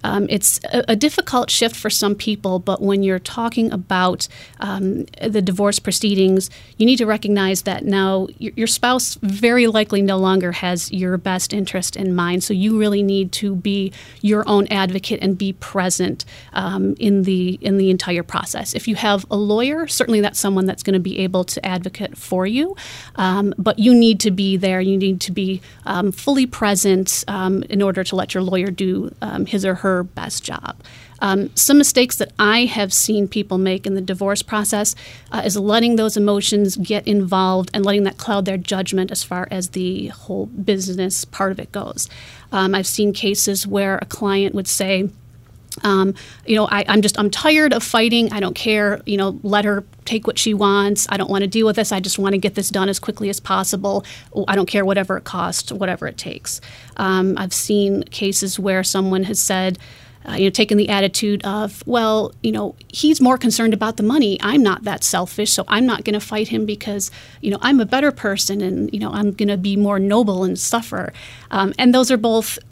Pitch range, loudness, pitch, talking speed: 190-215 Hz, -18 LUFS, 200 Hz, 210 wpm